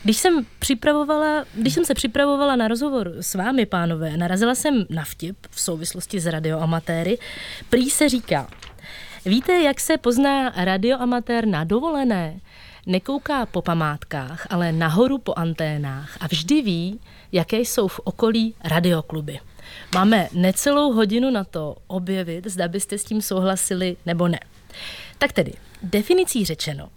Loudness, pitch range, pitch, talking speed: -21 LUFS, 170-250 Hz, 195 Hz, 140 wpm